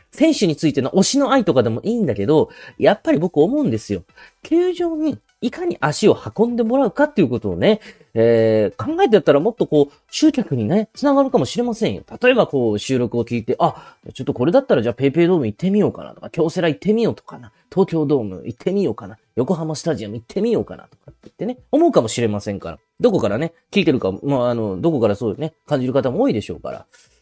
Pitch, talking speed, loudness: 160 Hz, 485 characters per minute, -18 LUFS